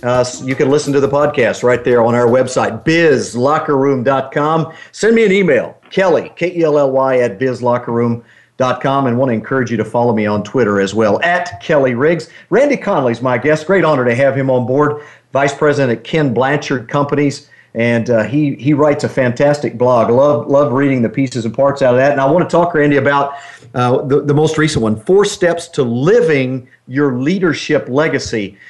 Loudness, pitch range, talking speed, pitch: -13 LUFS, 125-150 Hz, 200 wpm, 135 Hz